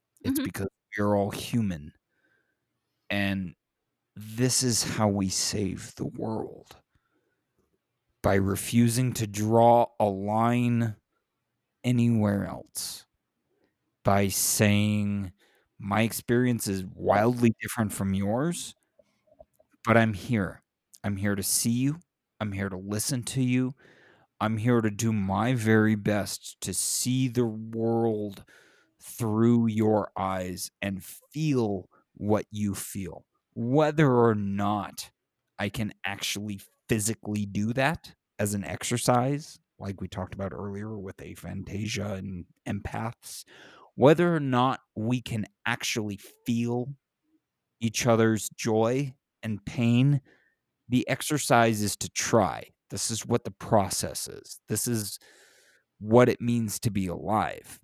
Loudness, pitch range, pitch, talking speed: -27 LUFS, 100-120 Hz, 110 Hz, 120 wpm